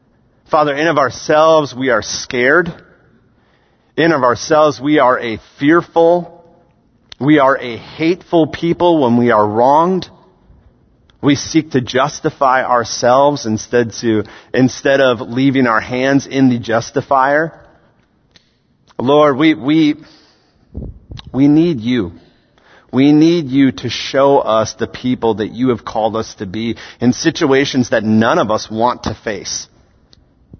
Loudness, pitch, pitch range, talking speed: -14 LUFS, 130 Hz, 115-150 Hz, 135 wpm